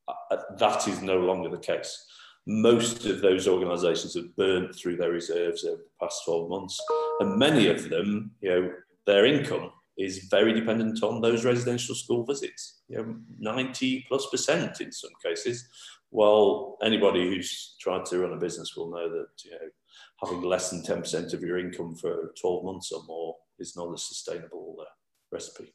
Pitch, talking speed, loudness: 130 Hz, 180 wpm, -27 LUFS